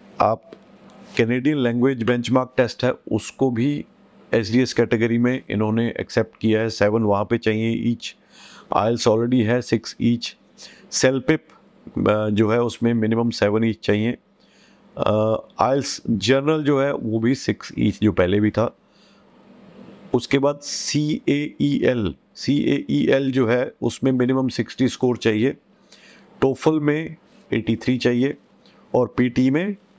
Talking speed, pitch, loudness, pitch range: 140 wpm, 120 Hz, -21 LUFS, 115-135 Hz